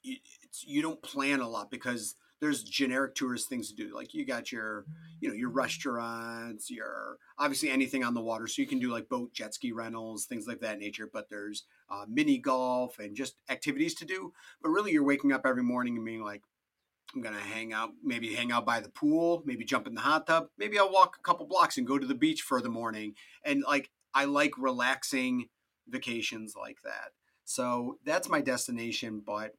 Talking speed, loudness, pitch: 210 wpm, -32 LUFS, 135 Hz